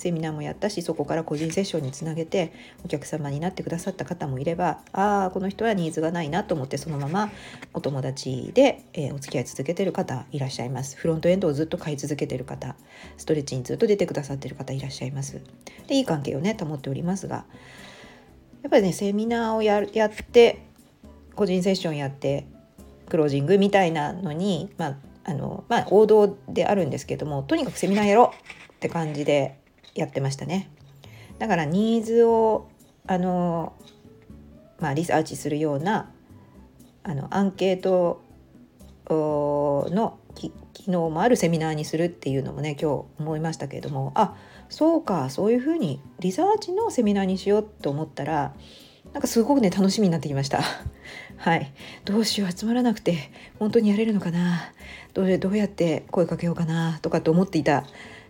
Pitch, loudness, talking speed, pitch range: 165 Hz, -24 LUFS, 390 characters per minute, 145-200 Hz